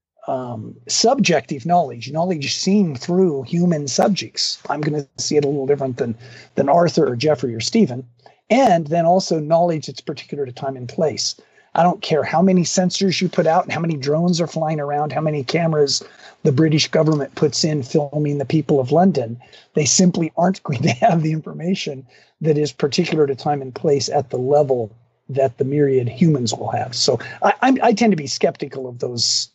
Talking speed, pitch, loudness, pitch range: 195 wpm, 155 Hz, -18 LUFS, 140-170 Hz